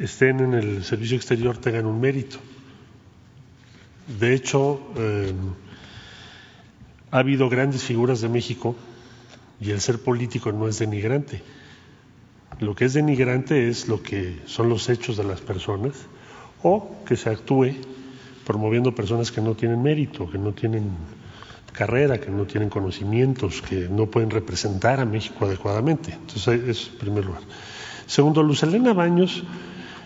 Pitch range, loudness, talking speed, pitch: 105-130 Hz, -23 LUFS, 140 wpm, 120 Hz